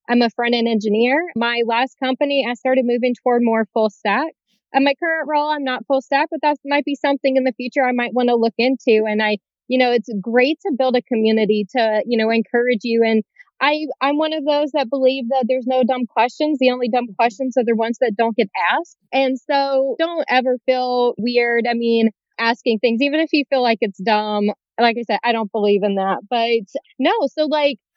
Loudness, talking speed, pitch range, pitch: -18 LUFS, 225 wpm, 230-275 Hz, 250 Hz